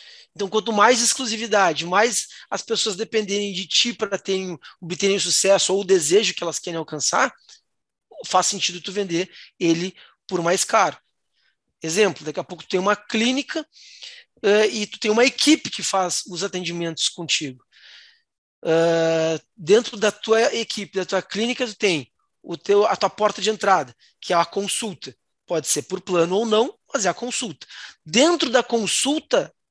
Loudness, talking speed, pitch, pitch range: -21 LUFS, 165 wpm, 195 Hz, 175-220 Hz